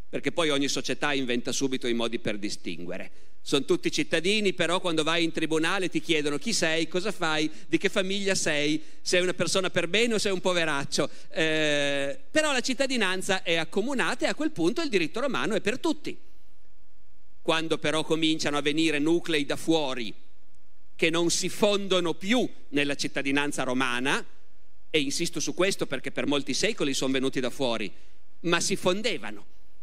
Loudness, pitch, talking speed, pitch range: -27 LUFS, 165 Hz, 170 wpm, 145-195 Hz